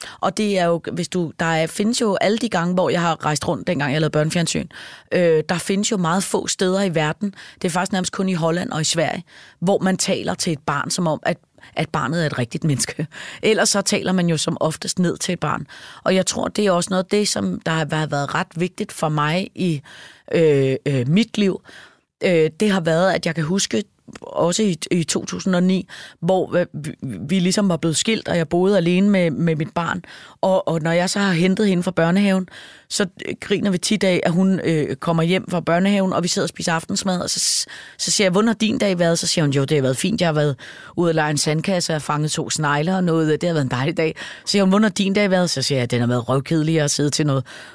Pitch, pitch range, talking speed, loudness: 175 Hz, 160-190 Hz, 250 wpm, -20 LUFS